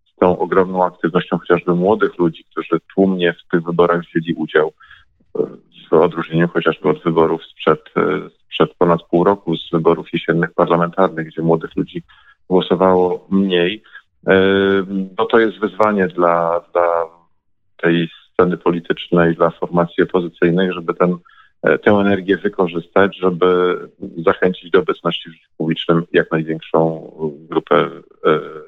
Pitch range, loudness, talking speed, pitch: 85-95 Hz, -17 LUFS, 125 wpm, 90 Hz